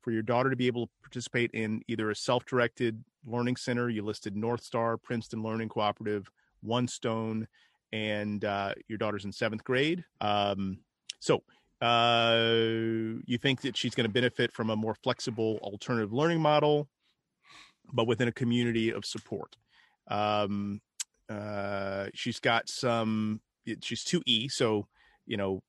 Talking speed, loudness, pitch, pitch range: 150 wpm, -31 LUFS, 115 Hz, 105-120 Hz